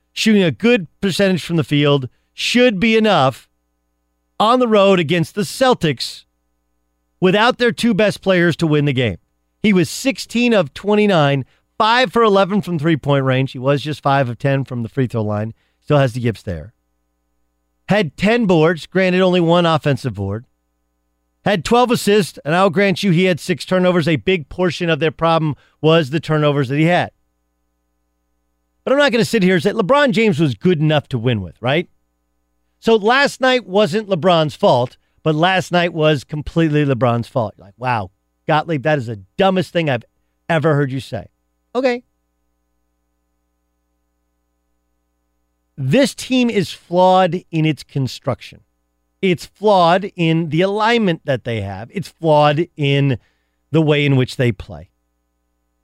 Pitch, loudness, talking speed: 145 Hz, -16 LUFS, 165 wpm